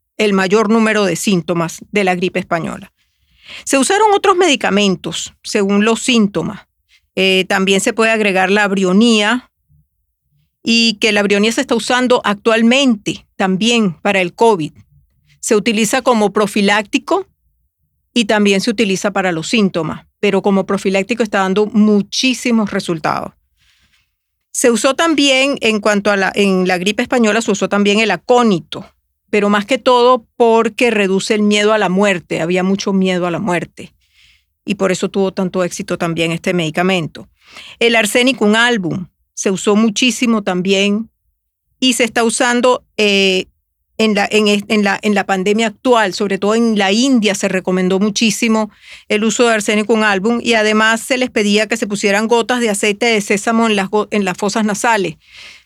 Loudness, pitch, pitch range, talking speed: -14 LUFS, 210 Hz, 190-230 Hz, 160 wpm